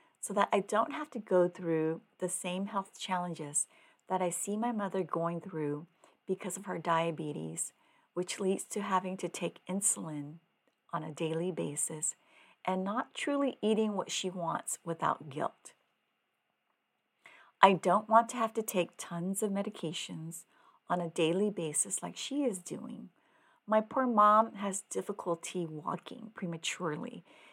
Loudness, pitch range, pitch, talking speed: -33 LUFS, 170-210 Hz, 185 Hz, 150 wpm